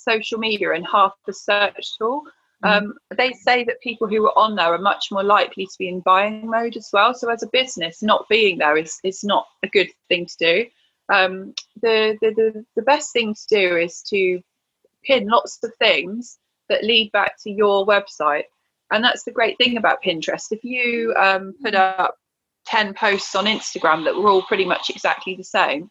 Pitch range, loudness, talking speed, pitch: 190-235 Hz, -19 LUFS, 200 wpm, 215 Hz